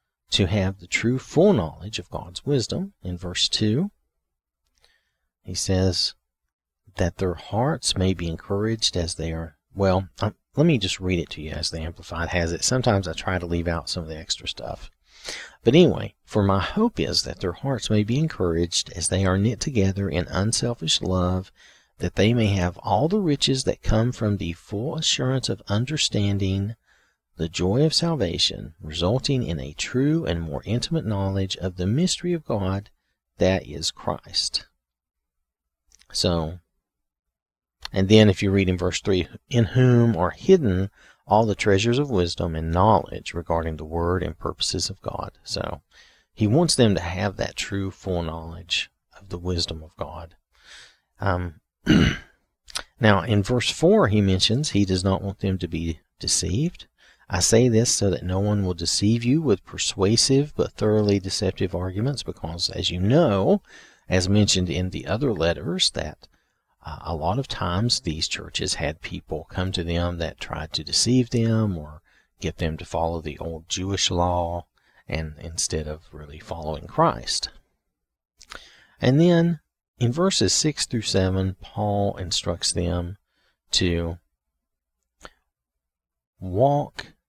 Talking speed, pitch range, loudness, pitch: 160 wpm, 85-110 Hz, -23 LUFS, 95 Hz